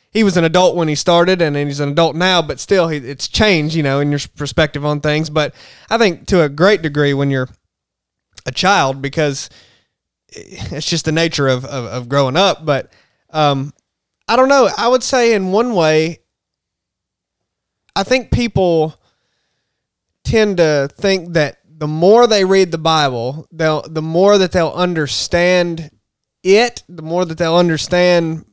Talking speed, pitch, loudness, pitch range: 170 wpm, 160 Hz, -14 LUFS, 145-180 Hz